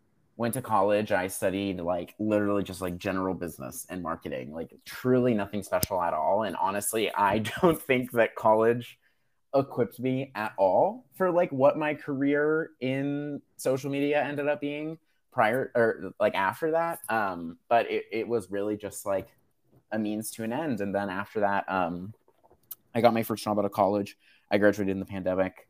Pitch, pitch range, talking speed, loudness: 110 Hz, 100-135 Hz, 180 wpm, -28 LUFS